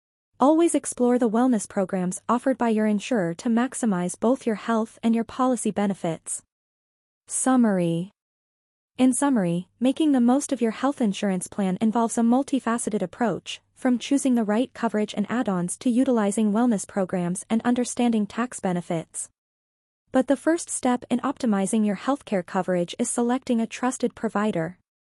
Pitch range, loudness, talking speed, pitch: 195-250 Hz, -24 LUFS, 150 wpm, 230 Hz